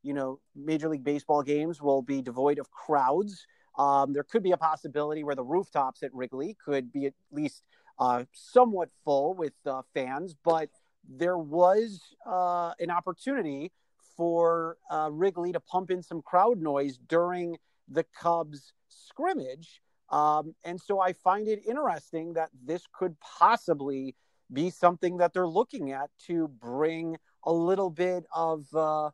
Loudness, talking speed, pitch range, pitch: -29 LUFS, 155 wpm, 145-180 Hz, 165 Hz